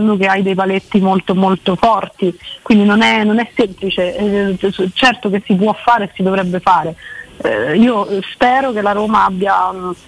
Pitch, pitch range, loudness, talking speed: 200 Hz, 190-220 Hz, -14 LUFS, 165 wpm